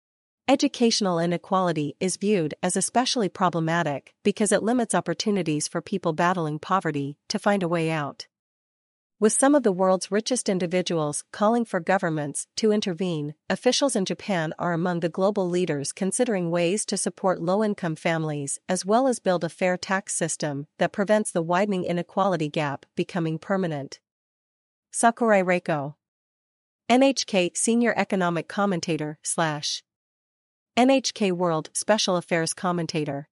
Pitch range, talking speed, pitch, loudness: 165-205 Hz, 135 wpm, 180 Hz, -24 LUFS